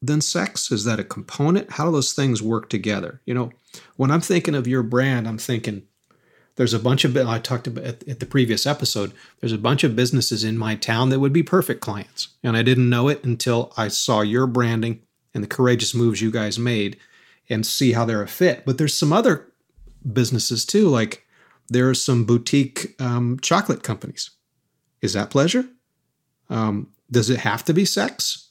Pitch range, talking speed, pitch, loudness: 115-140 Hz, 200 wpm, 125 Hz, -21 LUFS